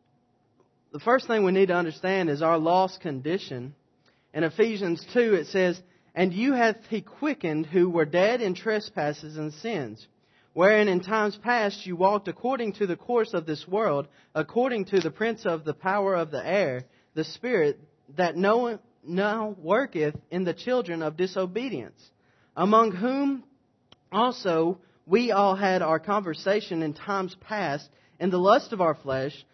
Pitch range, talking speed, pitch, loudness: 155-215 Hz, 160 wpm, 185 Hz, -26 LUFS